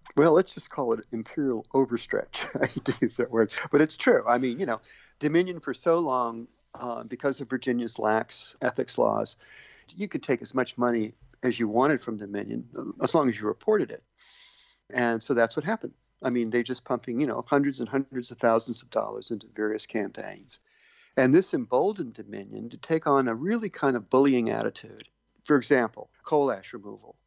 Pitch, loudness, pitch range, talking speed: 125 Hz, -27 LUFS, 115-155 Hz, 190 wpm